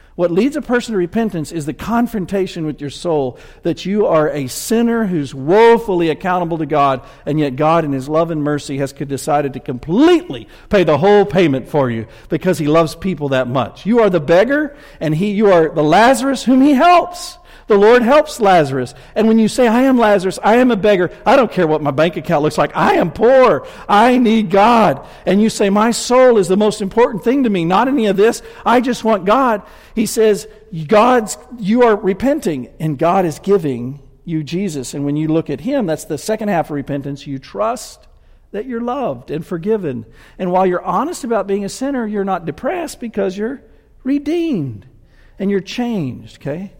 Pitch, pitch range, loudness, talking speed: 190 Hz, 150-230 Hz, -15 LUFS, 205 wpm